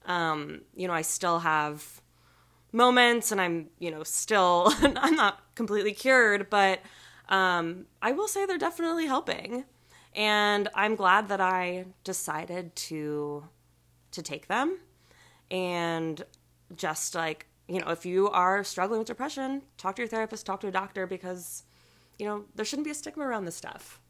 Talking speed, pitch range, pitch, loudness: 160 wpm, 165-220 Hz, 190 Hz, -28 LUFS